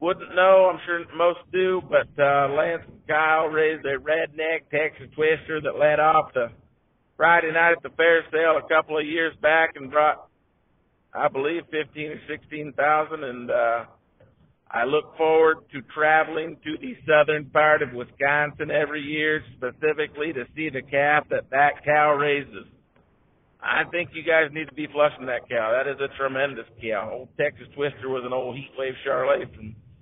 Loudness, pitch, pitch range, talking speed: -23 LUFS, 150 Hz, 140-160 Hz, 170 wpm